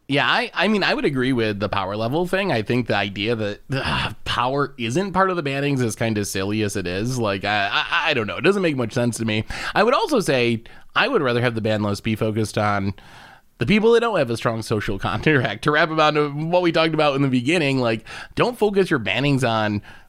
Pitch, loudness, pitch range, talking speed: 120 Hz, -21 LUFS, 110-150 Hz, 250 wpm